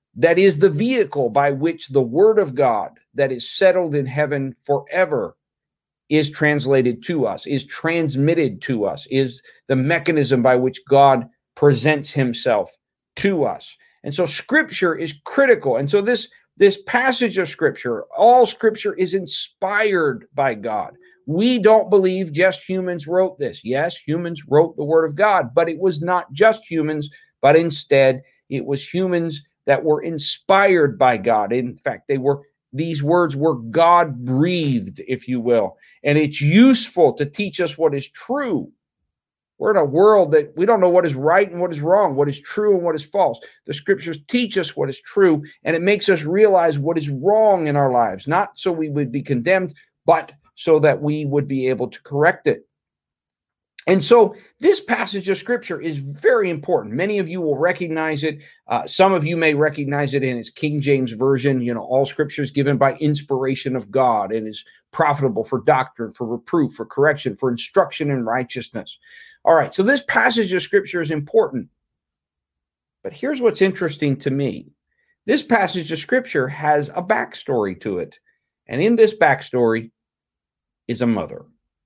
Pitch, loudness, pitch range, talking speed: 155 Hz, -19 LUFS, 140-190 Hz, 175 wpm